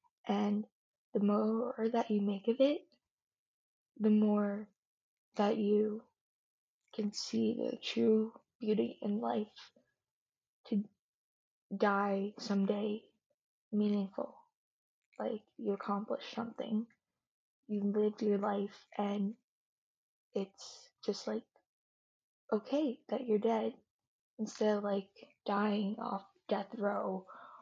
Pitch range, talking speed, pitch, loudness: 205-235 Hz, 100 wpm, 215 Hz, -36 LUFS